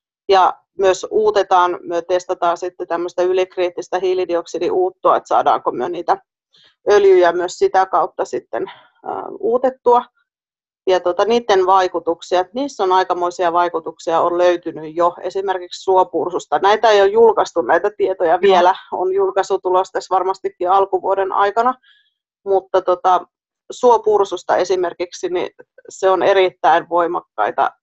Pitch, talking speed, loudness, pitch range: 190 Hz, 115 wpm, -17 LUFS, 180-210 Hz